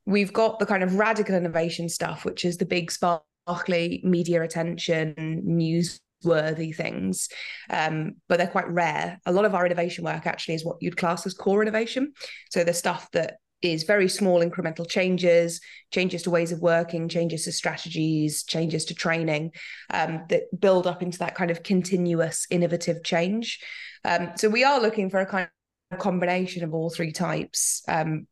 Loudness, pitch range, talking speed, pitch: -25 LUFS, 165-185 Hz, 175 wpm, 175 Hz